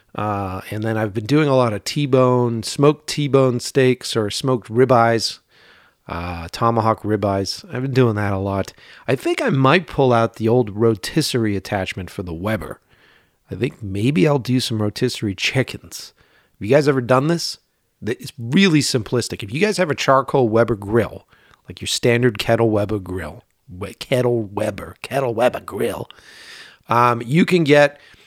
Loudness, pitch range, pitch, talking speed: -19 LUFS, 105-135 Hz, 120 Hz, 165 wpm